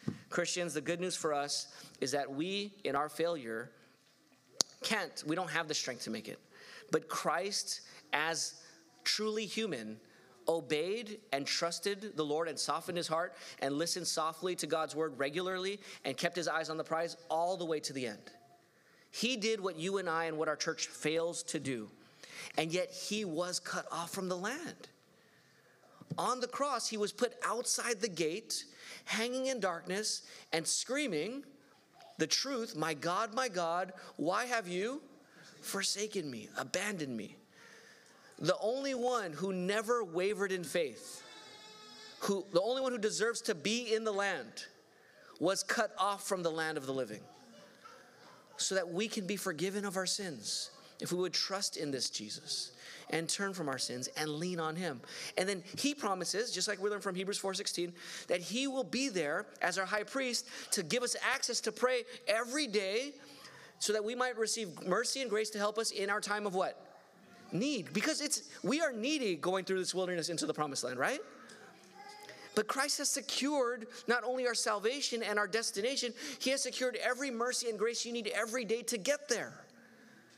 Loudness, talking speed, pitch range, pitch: -35 LUFS, 180 wpm, 170-235 Hz, 200 Hz